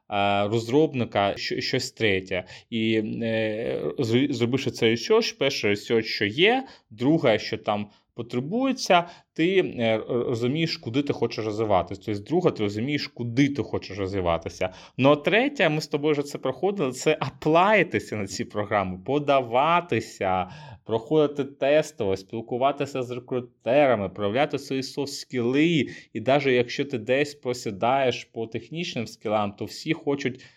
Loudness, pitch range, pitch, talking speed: -25 LUFS, 110-145 Hz, 125 Hz, 130 wpm